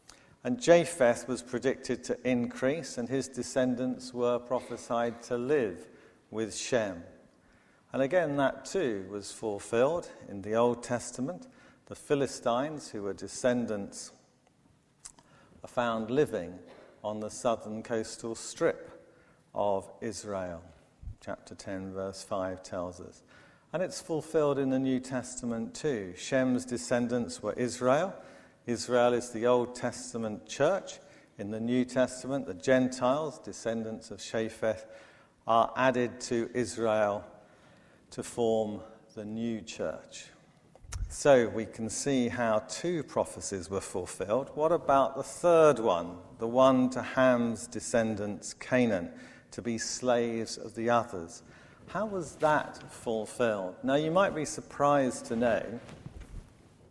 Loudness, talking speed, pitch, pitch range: -31 LUFS, 125 wpm, 120 Hz, 110-130 Hz